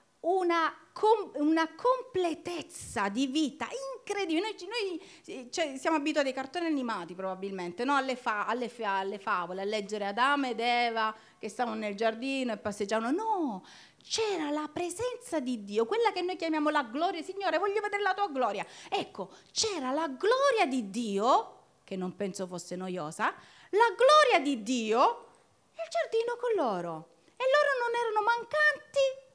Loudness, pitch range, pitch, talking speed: -30 LUFS, 225-375 Hz, 300 Hz, 155 wpm